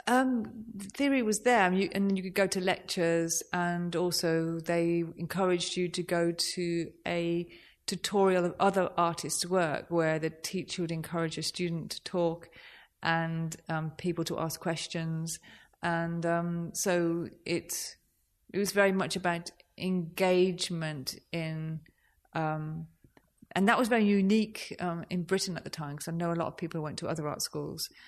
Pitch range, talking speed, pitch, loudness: 165-185 Hz, 165 wpm, 170 Hz, -31 LUFS